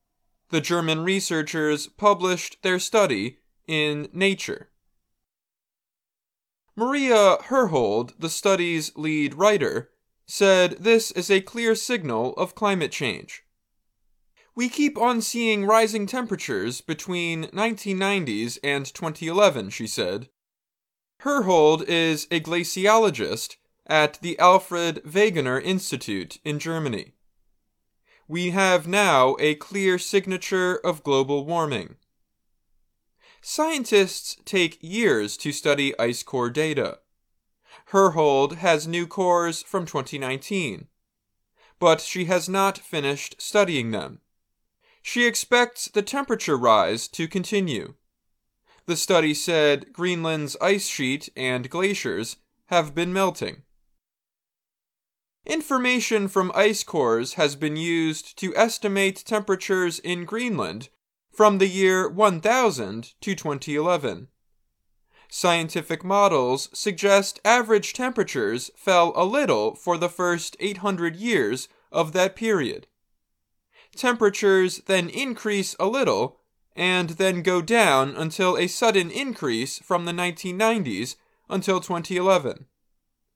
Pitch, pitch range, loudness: 185 Hz, 160-210 Hz, -23 LUFS